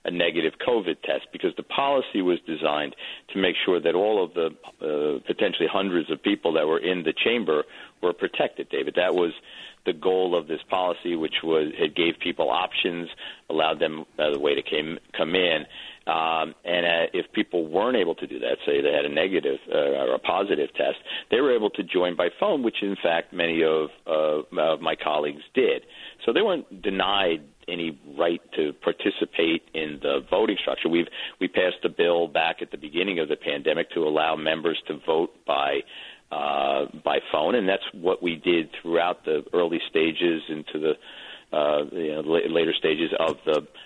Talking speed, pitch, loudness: 190 wpm, 85 Hz, -25 LUFS